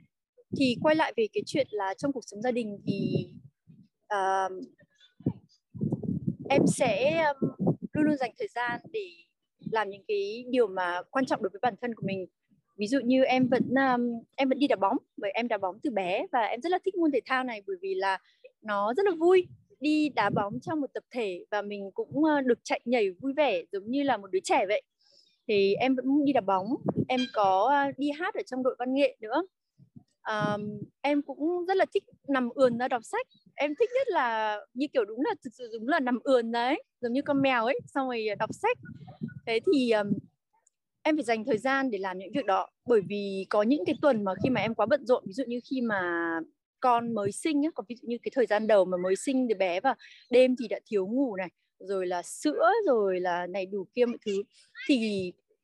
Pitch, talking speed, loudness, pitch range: 250 Hz, 225 wpm, -29 LUFS, 205-290 Hz